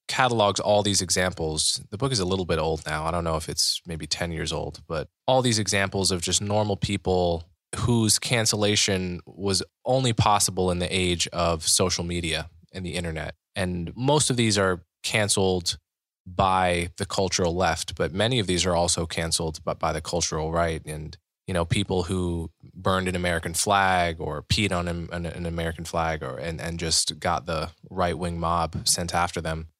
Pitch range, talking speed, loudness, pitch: 85-100 Hz, 185 wpm, -25 LUFS, 90 Hz